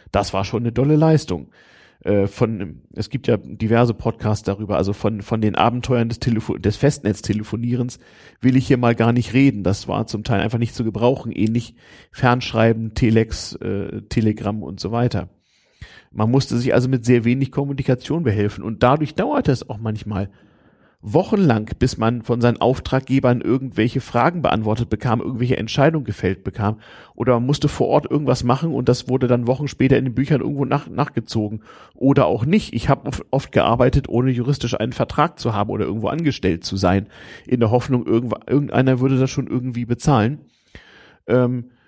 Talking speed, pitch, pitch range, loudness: 175 wpm, 120 Hz, 105-130 Hz, -20 LUFS